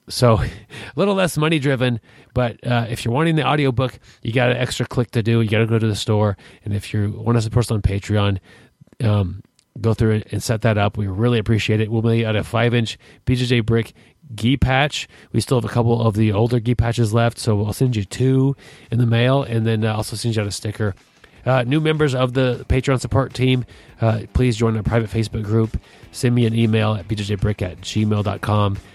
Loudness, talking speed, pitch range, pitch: -20 LUFS, 230 wpm, 110-125 Hz, 115 Hz